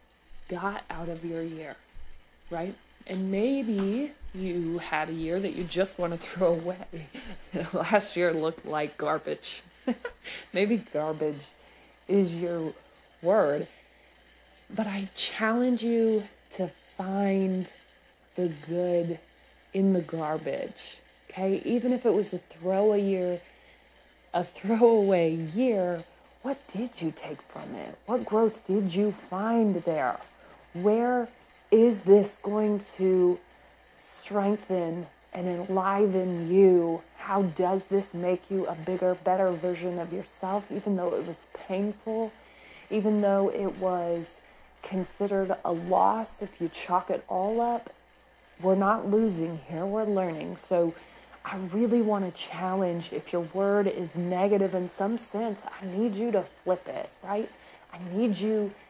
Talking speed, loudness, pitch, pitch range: 135 wpm, -28 LUFS, 190 Hz, 175-210 Hz